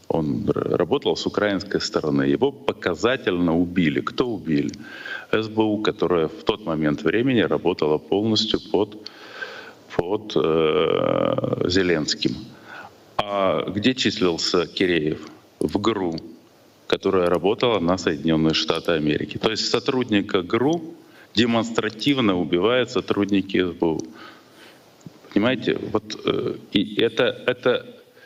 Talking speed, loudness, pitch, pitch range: 100 wpm, -22 LUFS, 100 Hz, 80-115 Hz